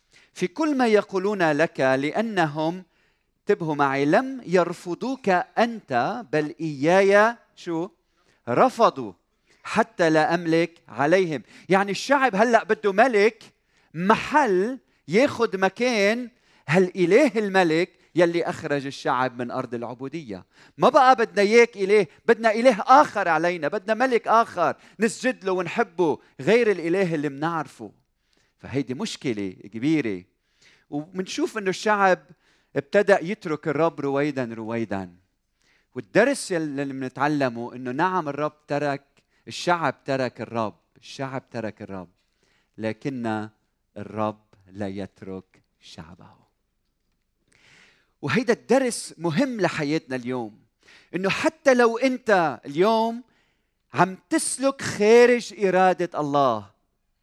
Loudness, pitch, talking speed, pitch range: -23 LUFS, 170 Hz, 105 wpm, 135-210 Hz